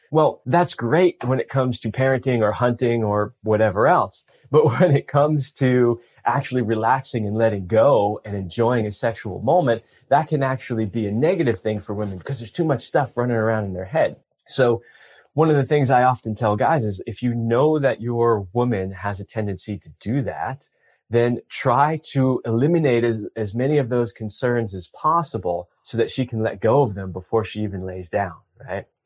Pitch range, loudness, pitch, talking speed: 105-130 Hz, -21 LUFS, 115 Hz, 195 wpm